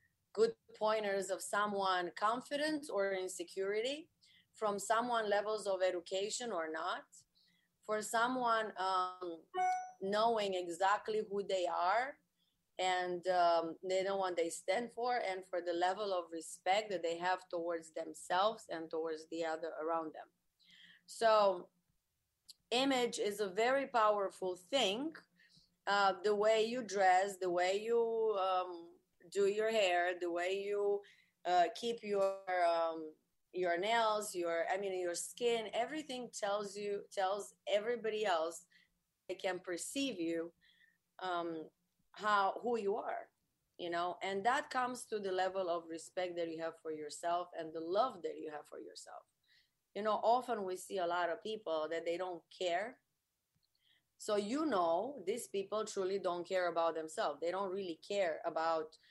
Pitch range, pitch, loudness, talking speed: 175-215 Hz, 190 Hz, -37 LUFS, 150 wpm